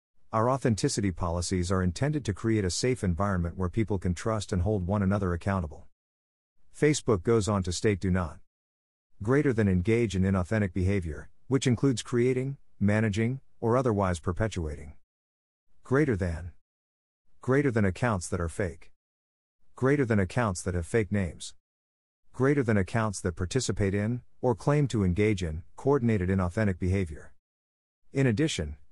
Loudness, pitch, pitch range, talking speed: -28 LUFS, 100 Hz, 85-115 Hz, 145 wpm